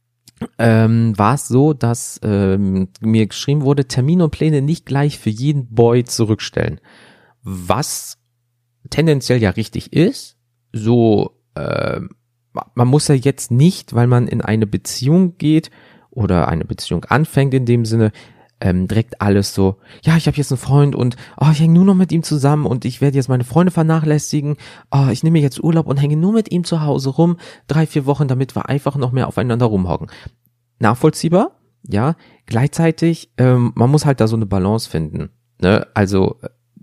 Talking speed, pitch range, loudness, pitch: 175 wpm, 115-150 Hz, -16 LUFS, 125 Hz